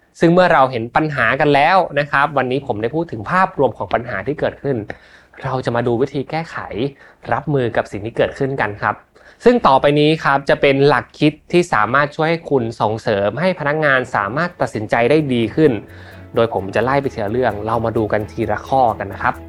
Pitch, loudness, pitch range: 135 Hz, -17 LUFS, 115-150 Hz